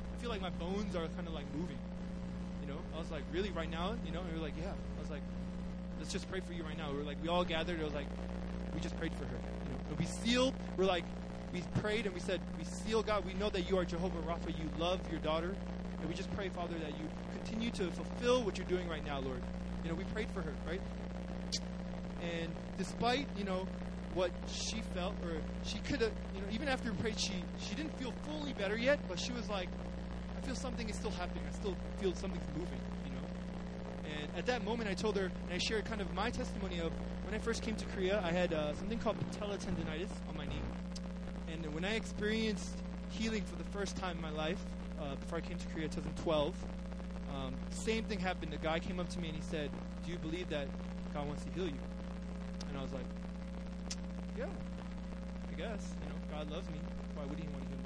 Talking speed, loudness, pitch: 230 wpm, -40 LUFS, 175 Hz